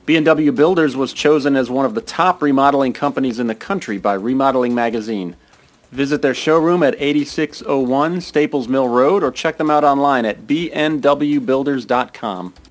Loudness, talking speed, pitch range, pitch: -16 LUFS, 150 wpm, 125-150 Hz, 140 Hz